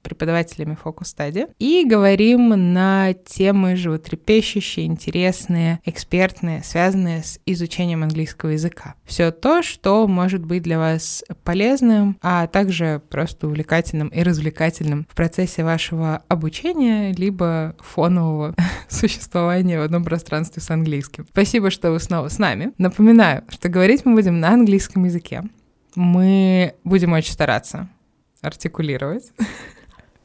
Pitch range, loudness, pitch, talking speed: 160-195 Hz, -18 LUFS, 175 Hz, 120 wpm